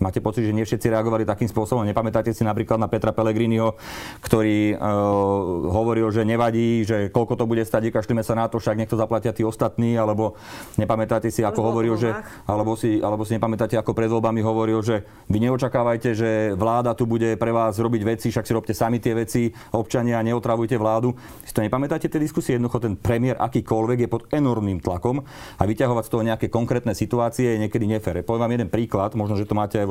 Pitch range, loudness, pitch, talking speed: 110-115 Hz, -22 LUFS, 115 Hz, 195 wpm